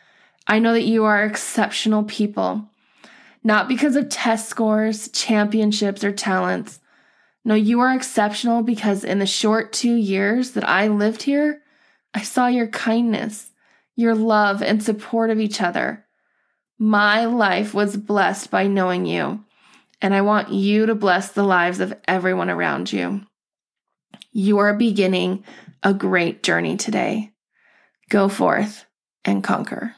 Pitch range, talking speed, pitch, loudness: 205-230 Hz, 140 wpm, 215 Hz, -20 LUFS